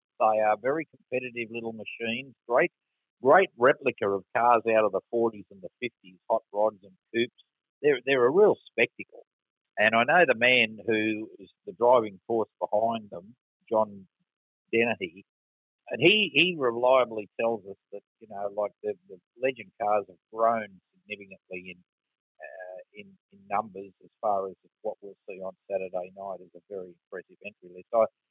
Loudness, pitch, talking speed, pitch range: -26 LUFS, 110 Hz, 165 wpm, 95-120 Hz